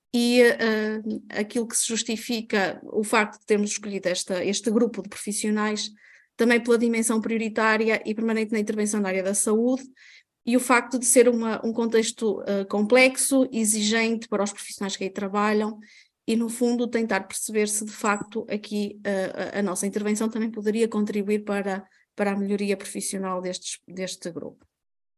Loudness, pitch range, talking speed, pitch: -24 LUFS, 200-230 Hz, 165 wpm, 215 Hz